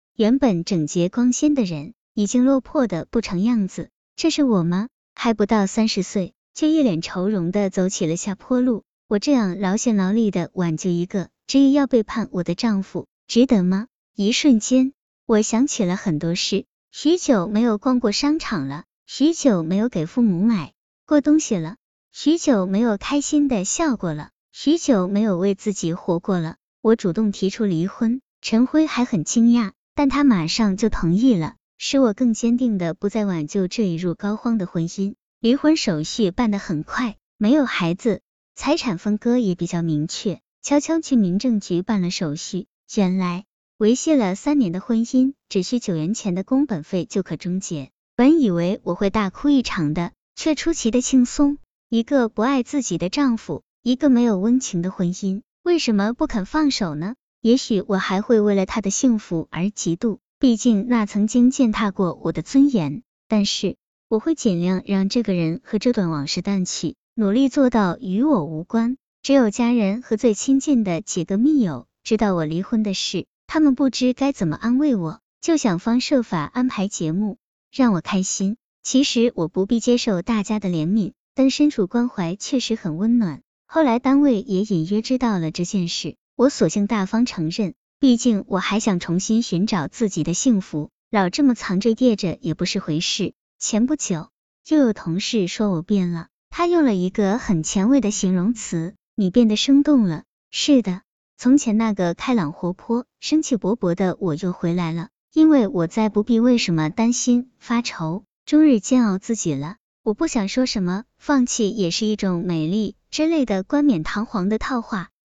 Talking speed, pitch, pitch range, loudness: 260 characters per minute, 215 Hz, 185-250 Hz, -20 LUFS